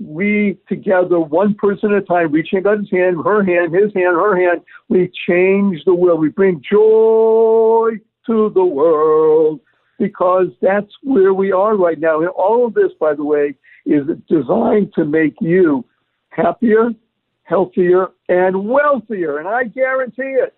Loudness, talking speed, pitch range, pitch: -15 LUFS, 155 wpm, 180-225 Hz, 200 Hz